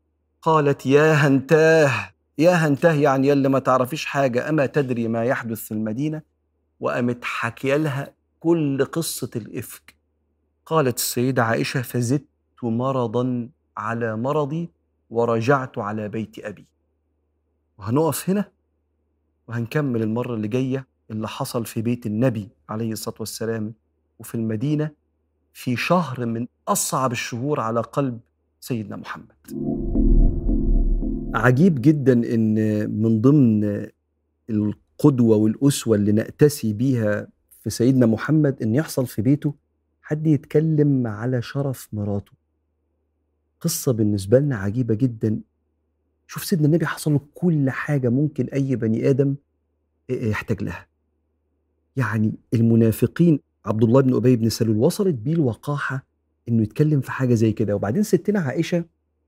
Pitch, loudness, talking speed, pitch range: 120 Hz, -21 LUFS, 120 wpm, 105-140 Hz